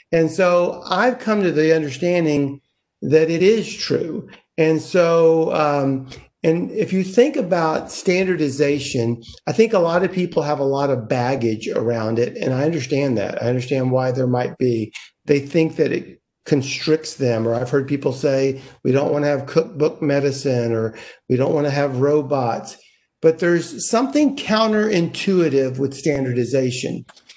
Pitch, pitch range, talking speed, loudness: 150 Hz, 135-175 Hz, 160 wpm, -19 LUFS